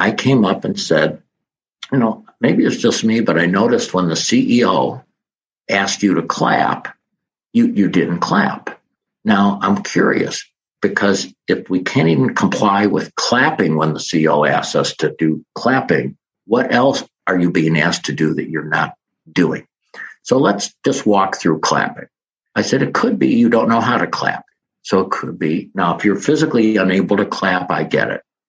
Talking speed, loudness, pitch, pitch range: 185 wpm, -16 LUFS, 95 Hz, 80-115 Hz